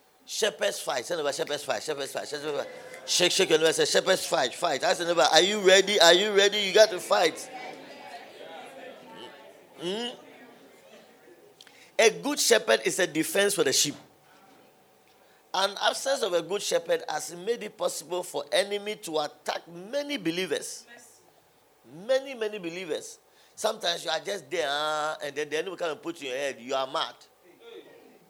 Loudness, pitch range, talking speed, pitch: -26 LUFS, 170-285 Hz, 145 wpm, 205 Hz